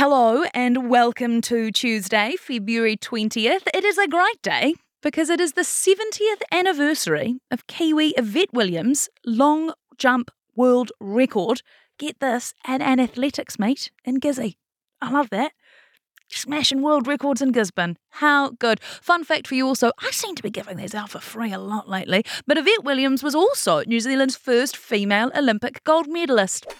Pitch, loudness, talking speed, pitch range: 260 Hz, -21 LUFS, 165 wpm, 230-300 Hz